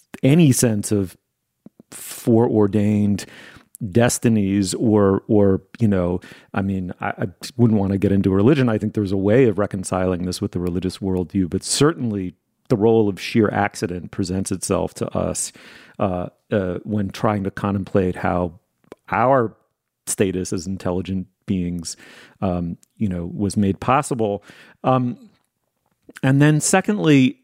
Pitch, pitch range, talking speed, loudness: 100 Hz, 95-115 Hz, 140 wpm, -20 LUFS